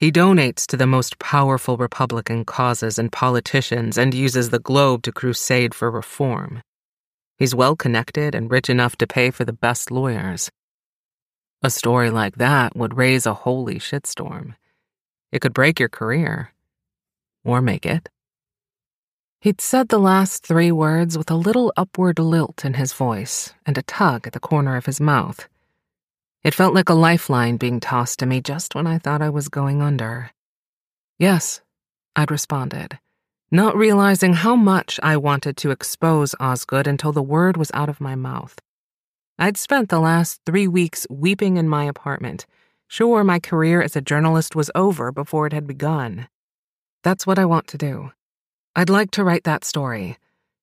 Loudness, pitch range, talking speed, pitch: -19 LUFS, 125-165 Hz, 165 wpm, 145 Hz